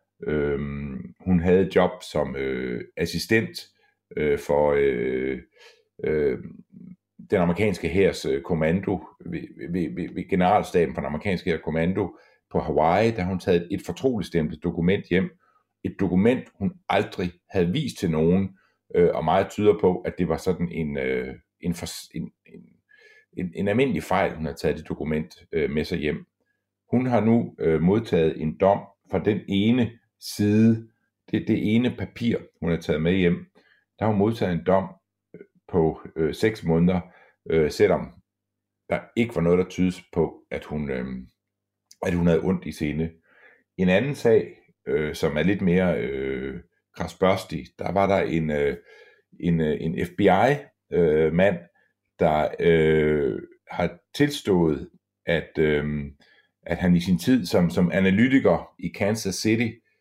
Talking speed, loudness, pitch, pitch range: 150 wpm, -24 LUFS, 90 Hz, 80-110 Hz